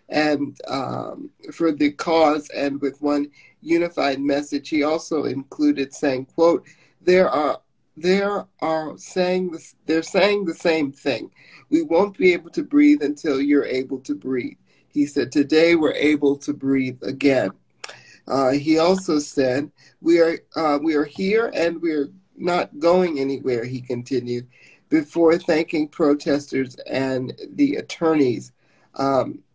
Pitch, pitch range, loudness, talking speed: 150 Hz, 140-170 Hz, -21 LUFS, 140 wpm